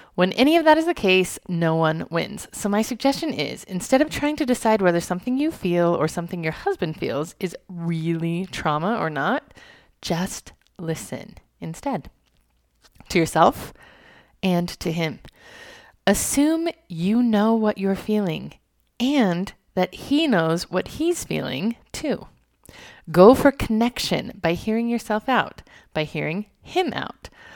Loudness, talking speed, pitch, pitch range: -22 LUFS, 145 wpm, 195 Hz, 170-255 Hz